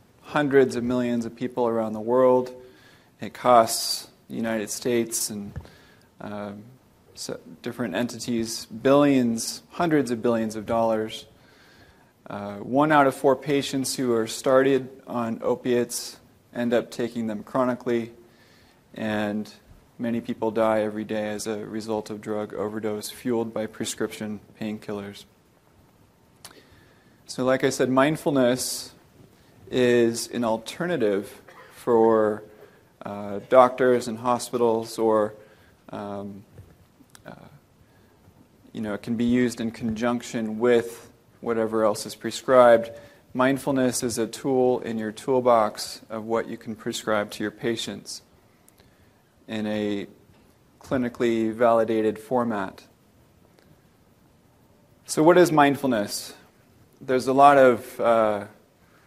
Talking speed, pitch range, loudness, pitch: 115 wpm, 110-125 Hz, -24 LUFS, 115 Hz